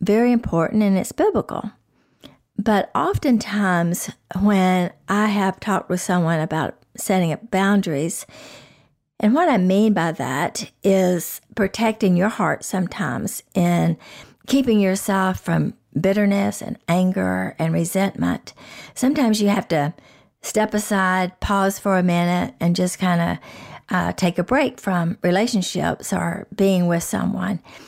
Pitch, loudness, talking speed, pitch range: 190 Hz, -20 LUFS, 130 wpm, 175-210 Hz